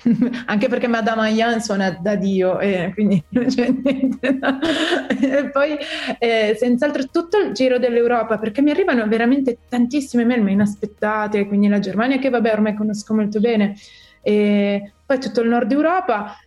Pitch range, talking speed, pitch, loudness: 210-265 Hz, 160 wpm, 235 Hz, -18 LUFS